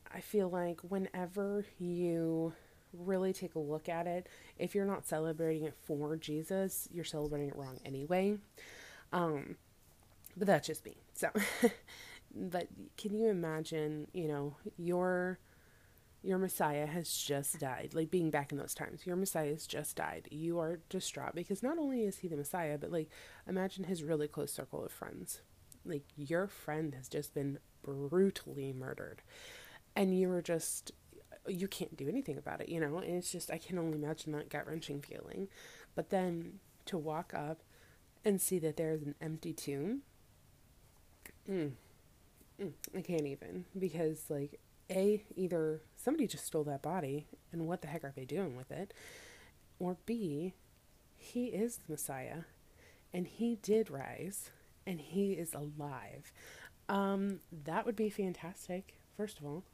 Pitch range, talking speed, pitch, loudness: 150-190 Hz, 160 wpm, 170 Hz, -39 LUFS